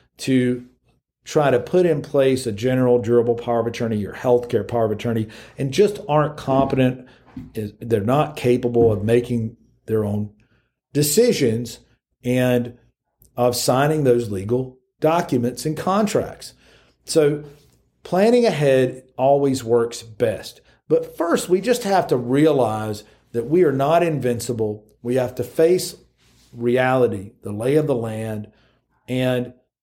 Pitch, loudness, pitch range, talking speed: 125 Hz, -20 LUFS, 115-145 Hz, 135 wpm